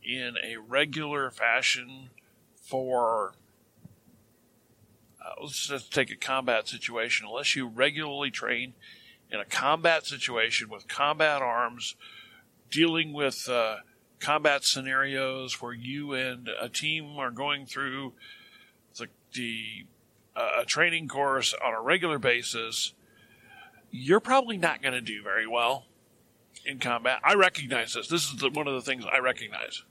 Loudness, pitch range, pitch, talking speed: -28 LUFS, 120-145 Hz, 130 Hz, 135 wpm